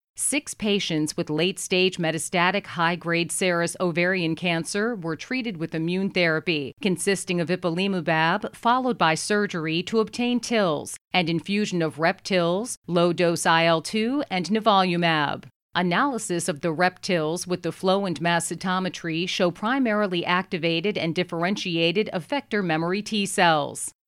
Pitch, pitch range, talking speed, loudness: 180 Hz, 165-200 Hz, 130 wpm, -24 LUFS